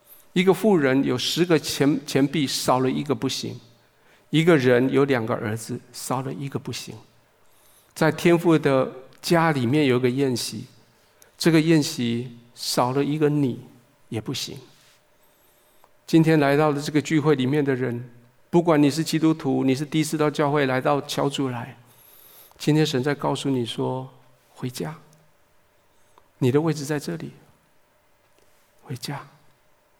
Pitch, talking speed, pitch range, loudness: 140 Hz, 210 characters per minute, 125-155 Hz, -22 LUFS